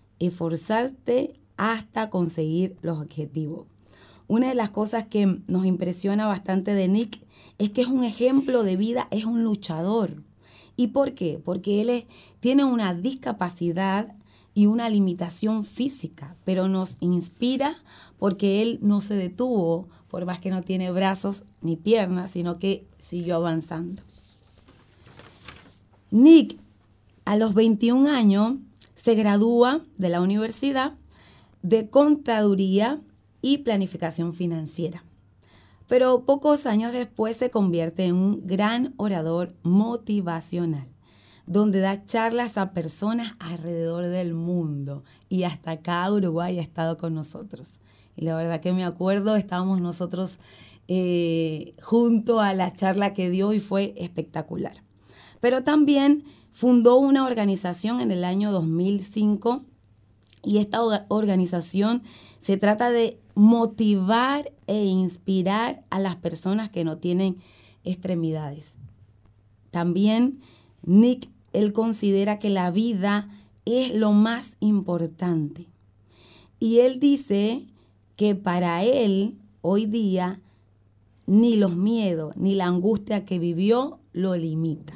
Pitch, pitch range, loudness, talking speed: 195 Hz, 170-225 Hz, -24 LUFS, 120 wpm